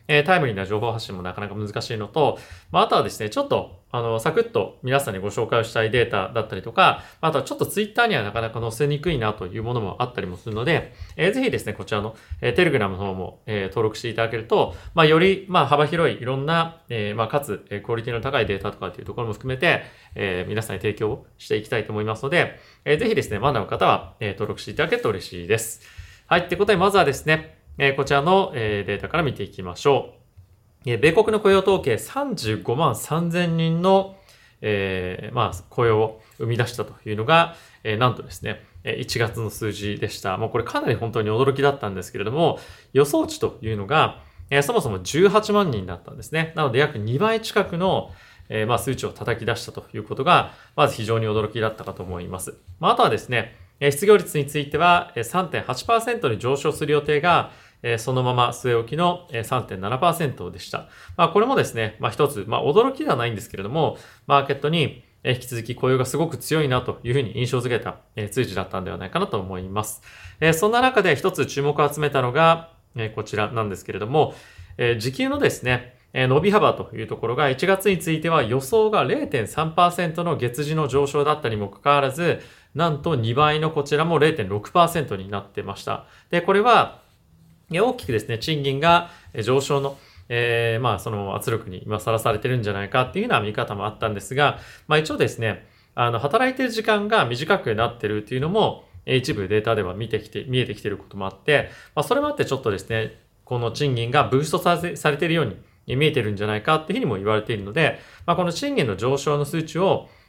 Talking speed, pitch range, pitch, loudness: 395 characters per minute, 110-155 Hz, 125 Hz, -22 LUFS